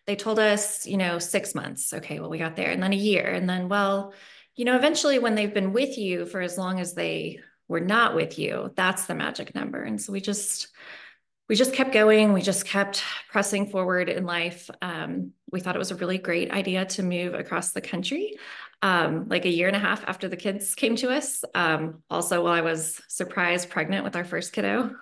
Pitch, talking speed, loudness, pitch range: 195 Hz, 225 wpm, -25 LUFS, 175-205 Hz